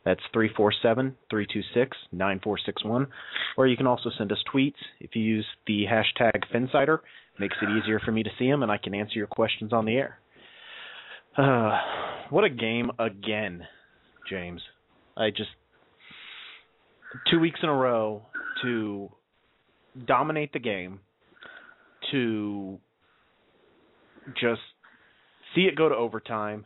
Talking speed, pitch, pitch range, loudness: 130 wpm, 110 Hz, 105-130 Hz, -27 LUFS